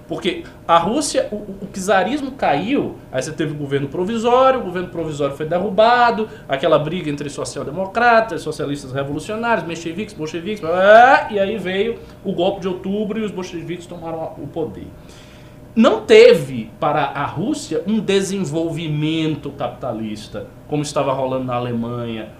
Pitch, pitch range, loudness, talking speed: 170 Hz, 145-210 Hz, -18 LUFS, 140 wpm